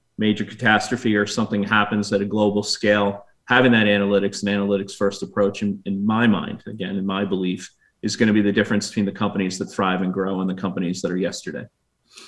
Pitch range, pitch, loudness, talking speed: 100-105 Hz, 105 Hz, -21 LUFS, 210 wpm